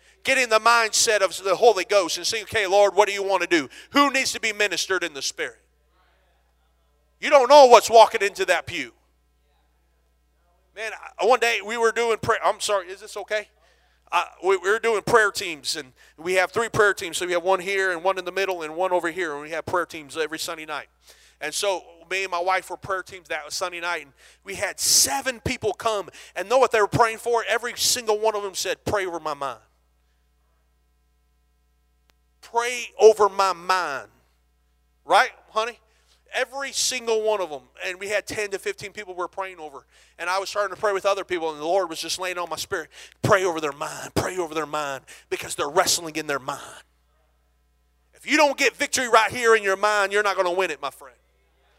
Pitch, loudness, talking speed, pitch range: 185 Hz, -22 LUFS, 220 wpm, 140-215 Hz